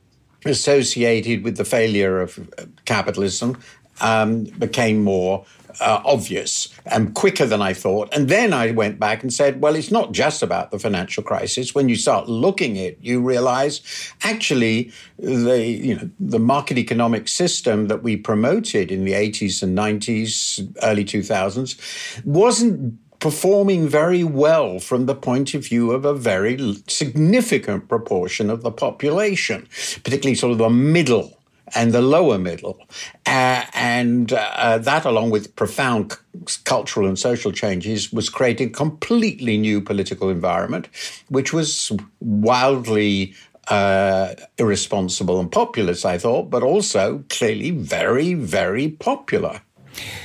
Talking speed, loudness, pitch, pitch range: 140 wpm, -19 LUFS, 120 Hz, 105-140 Hz